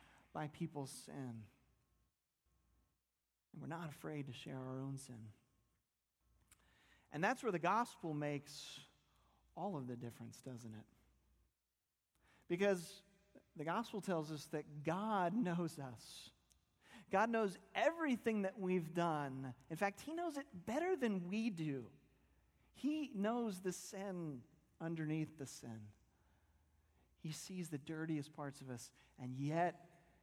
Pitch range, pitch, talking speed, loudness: 130-195 Hz, 155 Hz, 125 wpm, -43 LUFS